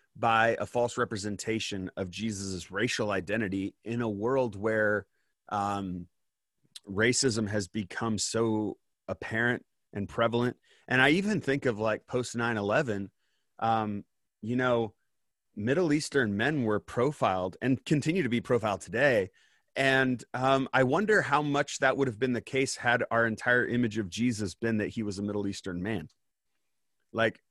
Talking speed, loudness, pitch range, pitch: 155 wpm, -29 LUFS, 105-125 Hz, 115 Hz